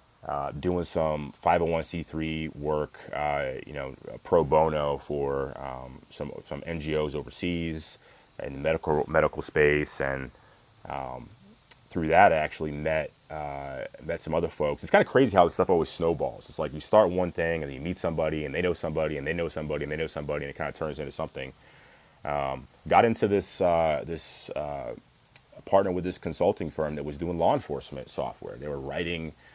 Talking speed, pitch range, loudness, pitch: 185 wpm, 75-85 Hz, -28 LUFS, 75 Hz